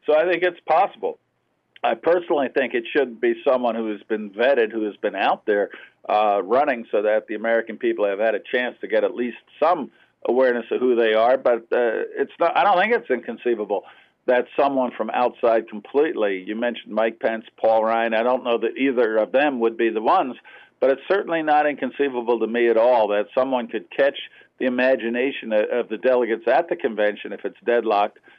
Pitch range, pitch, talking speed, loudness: 110-130 Hz, 120 Hz, 205 wpm, -21 LUFS